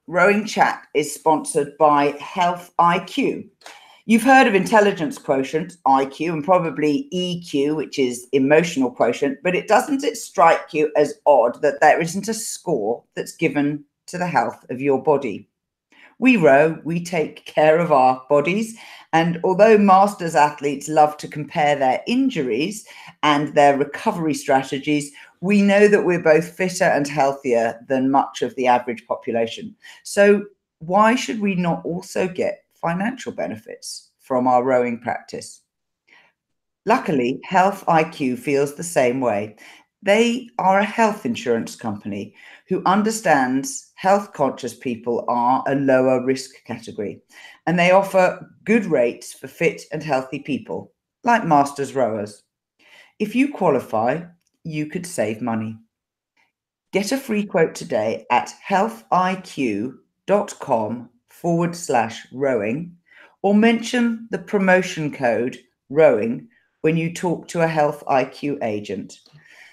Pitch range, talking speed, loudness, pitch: 140-195 Hz, 135 wpm, -19 LUFS, 160 Hz